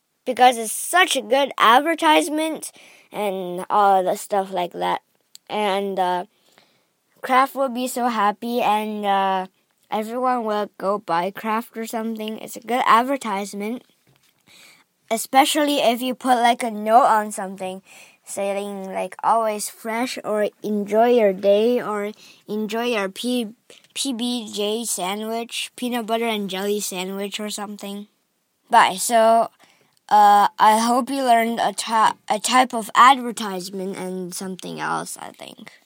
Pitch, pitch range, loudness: 215 Hz, 200-245 Hz, -20 LUFS